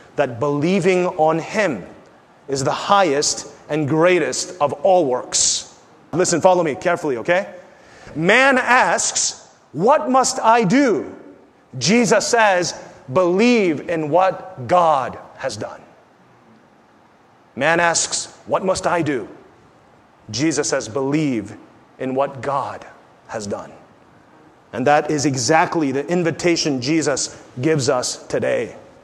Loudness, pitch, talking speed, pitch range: -18 LUFS, 160 Hz, 115 wpm, 145-185 Hz